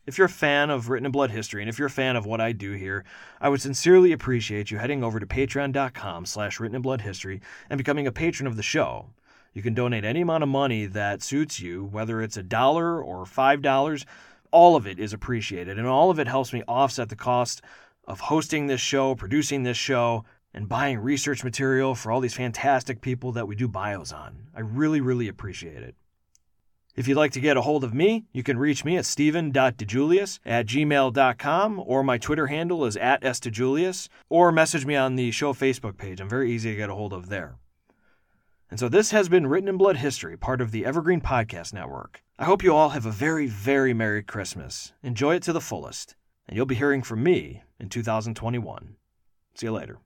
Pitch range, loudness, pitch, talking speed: 110-145 Hz, -24 LUFS, 130 Hz, 210 wpm